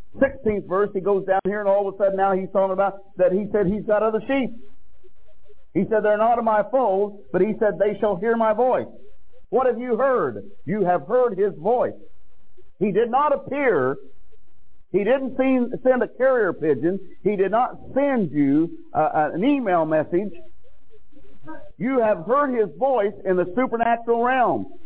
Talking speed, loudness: 180 wpm, -22 LUFS